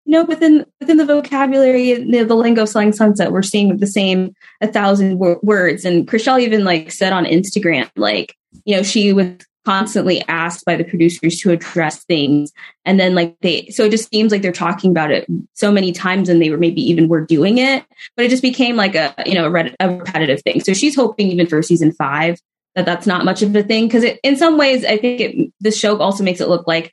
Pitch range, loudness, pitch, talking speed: 175-225 Hz, -15 LUFS, 195 Hz, 235 wpm